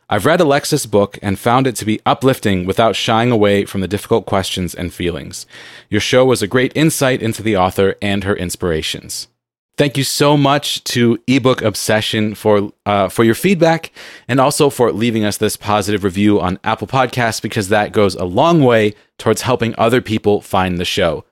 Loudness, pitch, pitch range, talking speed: -15 LUFS, 110 Hz, 100-130 Hz, 190 wpm